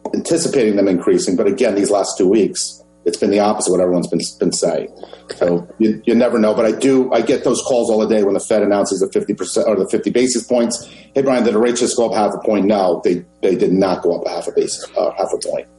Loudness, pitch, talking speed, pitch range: -16 LUFS, 110 Hz, 270 wpm, 100-125 Hz